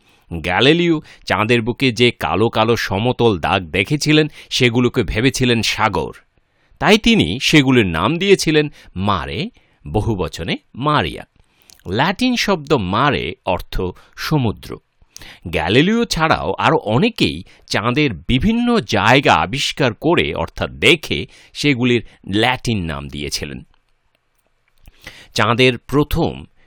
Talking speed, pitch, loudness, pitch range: 95 wpm, 120 Hz, -16 LUFS, 105-150 Hz